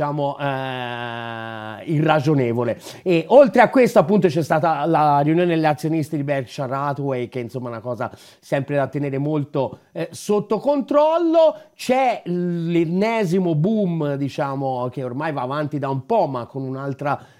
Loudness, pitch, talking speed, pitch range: -20 LUFS, 150 Hz, 145 wpm, 135-175 Hz